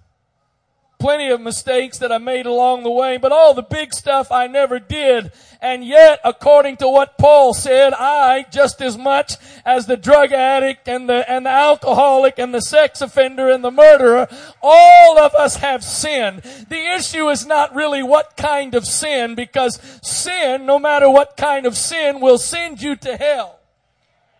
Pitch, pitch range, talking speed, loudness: 270 Hz, 250-290 Hz, 175 wpm, -13 LUFS